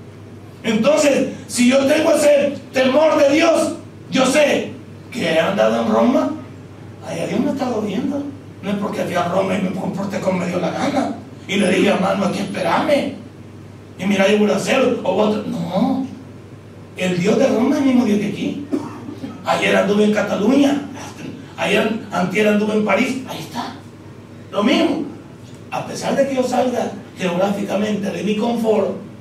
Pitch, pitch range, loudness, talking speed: 215 Hz, 185-265 Hz, -18 LUFS, 175 wpm